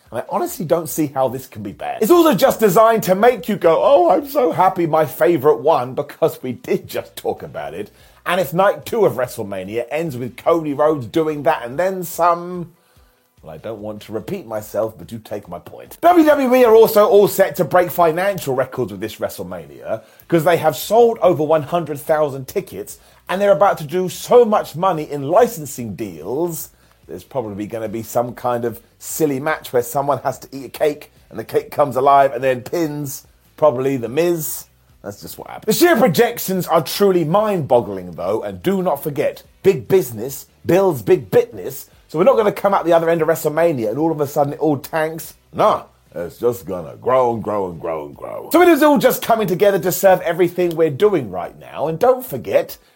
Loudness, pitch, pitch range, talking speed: -17 LUFS, 165 Hz, 130-190 Hz, 210 wpm